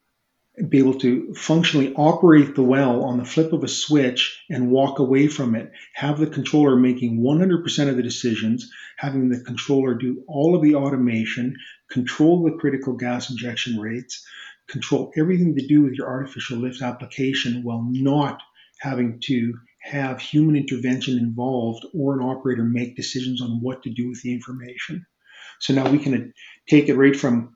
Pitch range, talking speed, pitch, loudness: 125-145 Hz, 170 wpm, 130 Hz, -21 LUFS